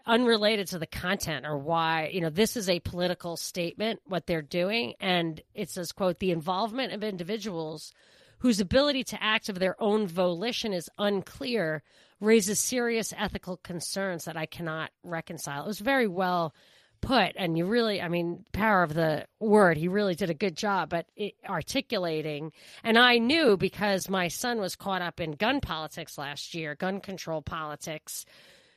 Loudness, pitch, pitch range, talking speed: -28 LUFS, 185 Hz, 165-215 Hz, 170 wpm